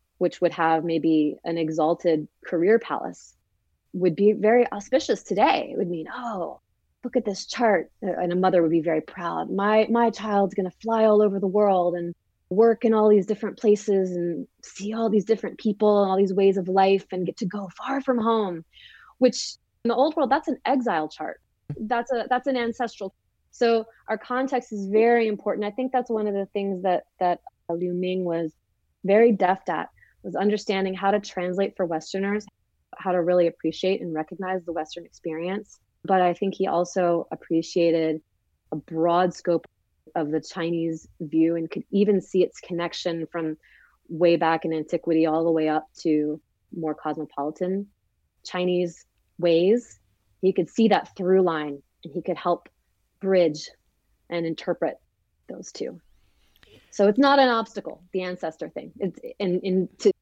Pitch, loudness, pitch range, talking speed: 185 Hz, -24 LUFS, 165-210 Hz, 175 wpm